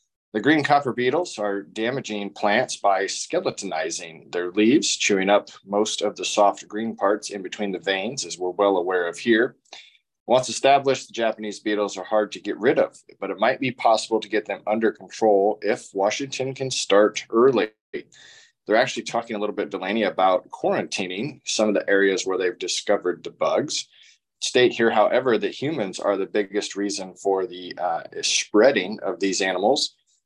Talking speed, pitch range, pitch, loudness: 175 wpm, 100-115 Hz, 105 Hz, -23 LUFS